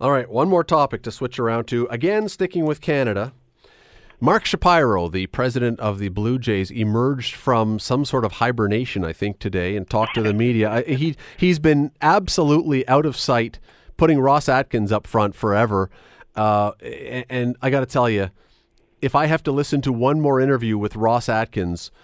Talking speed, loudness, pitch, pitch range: 185 wpm, -20 LUFS, 120 Hz, 110-140 Hz